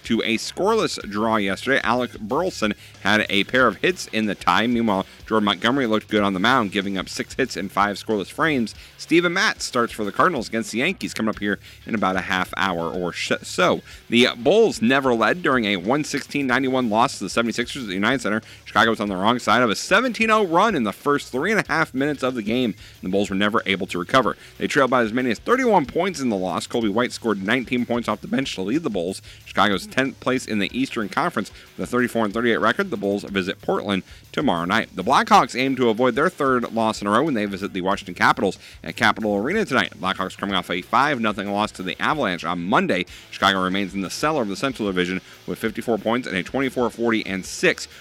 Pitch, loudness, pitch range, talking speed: 105 Hz, -21 LUFS, 95-125 Hz, 225 wpm